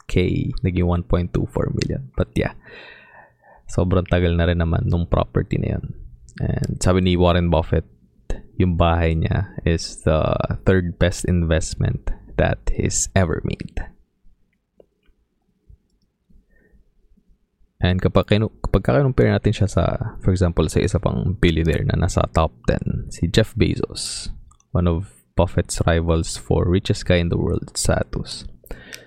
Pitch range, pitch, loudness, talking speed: 85-100 Hz, 90 Hz, -21 LUFS, 130 wpm